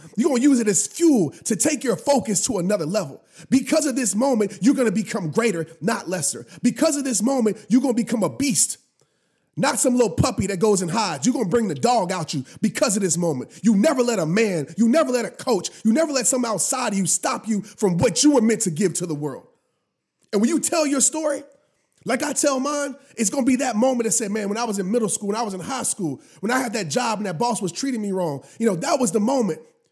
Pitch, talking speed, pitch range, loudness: 225 Hz, 255 wpm, 195-260 Hz, -21 LUFS